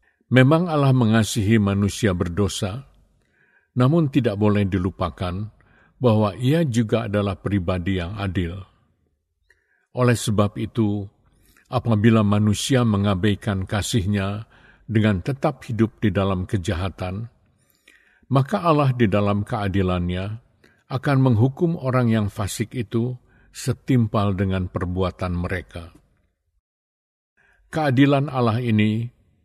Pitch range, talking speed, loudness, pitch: 95-125 Hz, 95 wpm, -21 LUFS, 110 Hz